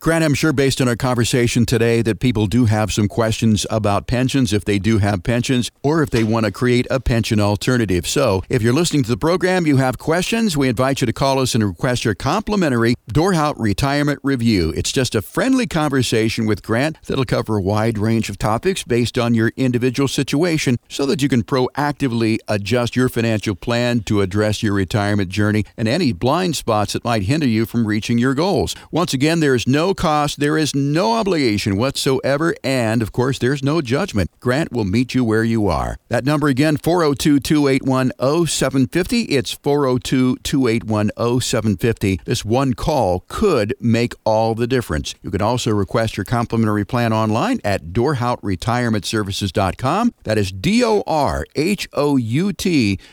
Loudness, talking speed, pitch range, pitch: -18 LUFS, 170 wpm, 110-140 Hz, 120 Hz